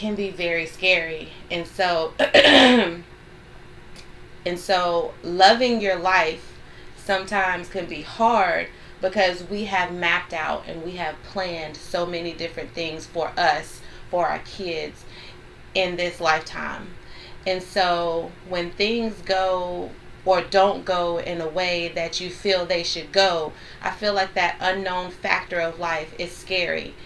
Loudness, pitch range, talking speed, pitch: -22 LUFS, 170-190 Hz, 140 wpm, 180 Hz